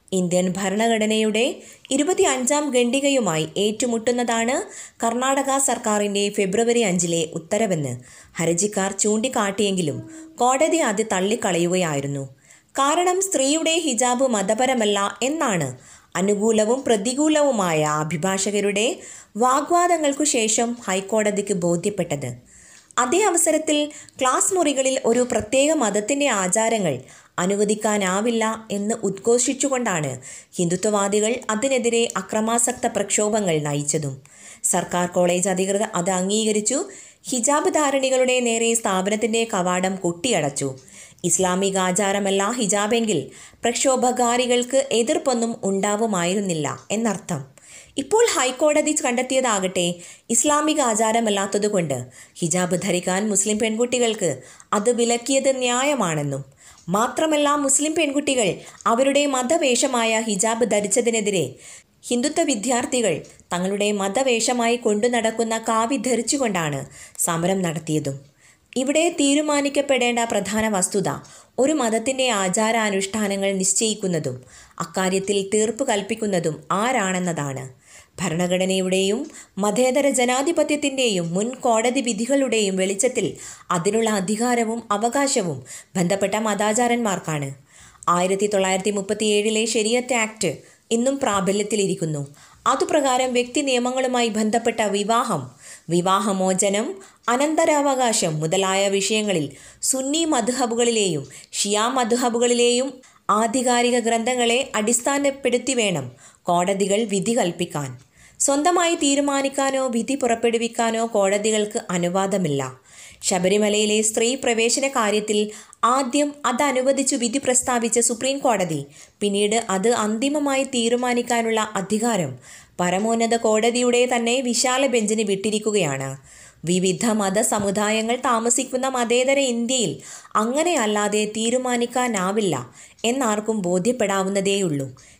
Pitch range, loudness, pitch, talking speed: 190-250 Hz, -21 LUFS, 220 Hz, 80 wpm